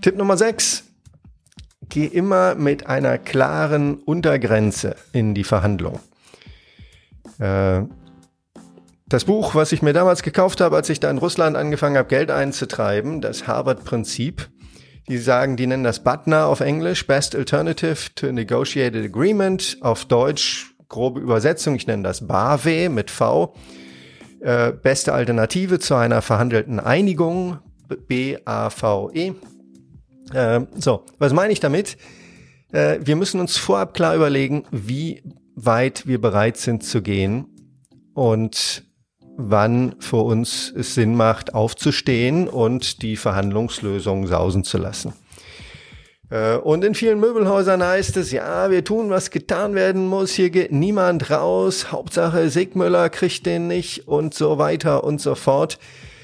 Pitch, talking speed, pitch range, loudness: 135 Hz, 130 wpm, 110-170 Hz, -19 LUFS